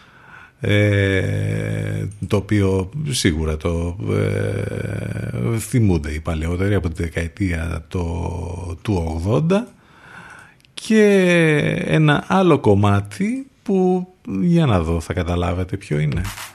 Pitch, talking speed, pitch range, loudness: 100 Hz, 100 wpm, 90-130 Hz, -19 LUFS